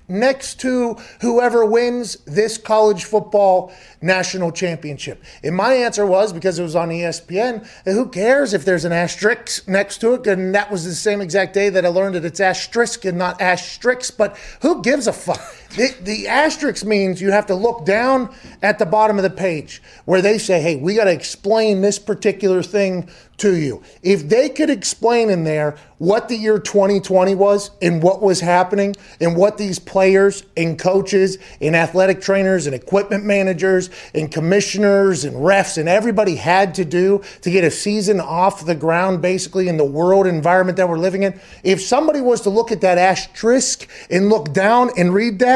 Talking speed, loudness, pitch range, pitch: 190 wpm, -17 LUFS, 180-215 Hz, 195 Hz